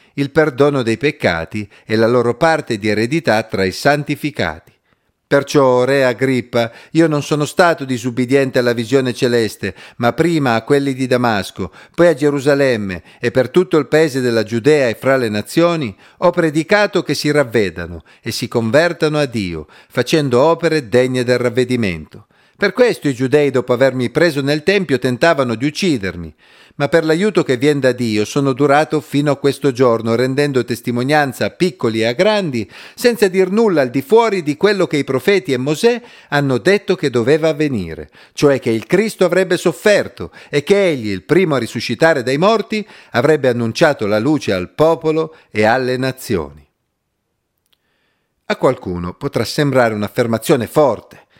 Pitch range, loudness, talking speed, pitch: 120-155 Hz, -15 LUFS, 160 wpm, 135 Hz